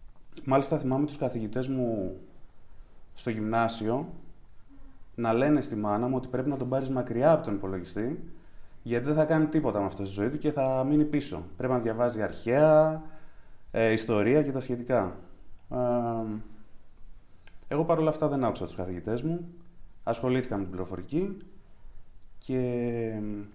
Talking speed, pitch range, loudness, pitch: 145 wpm, 105-145 Hz, -29 LUFS, 120 Hz